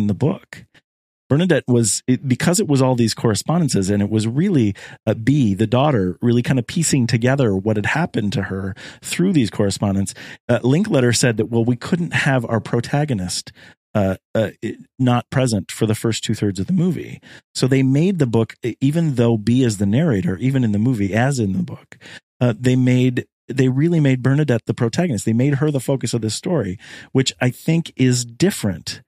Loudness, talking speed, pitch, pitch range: -19 LUFS, 200 wpm, 125 Hz, 110-135 Hz